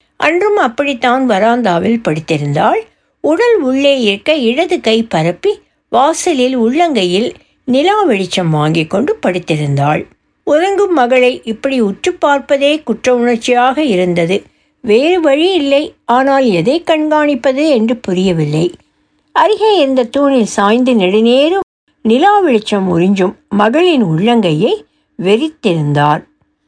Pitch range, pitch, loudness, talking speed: 195-300 Hz, 245 Hz, -12 LUFS, 100 wpm